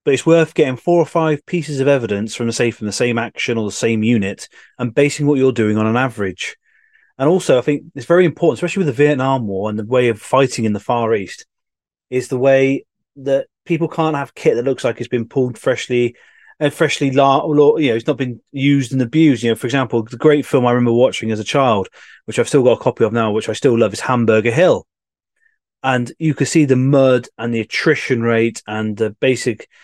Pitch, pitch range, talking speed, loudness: 130 Hz, 115-150 Hz, 235 wpm, -16 LUFS